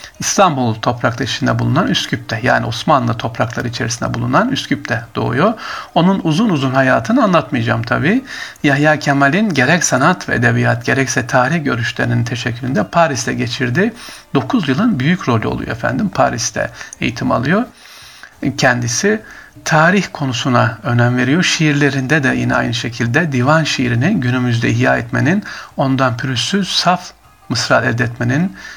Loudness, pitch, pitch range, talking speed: -15 LUFS, 130 Hz, 120-160 Hz, 125 wpm